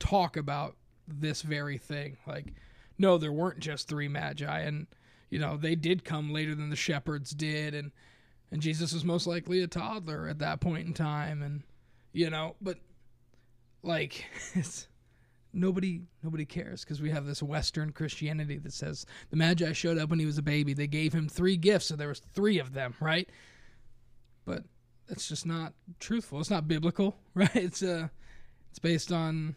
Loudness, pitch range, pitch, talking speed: -32 LUFS, 145-170 Hz, 155 Hz, 180 wpm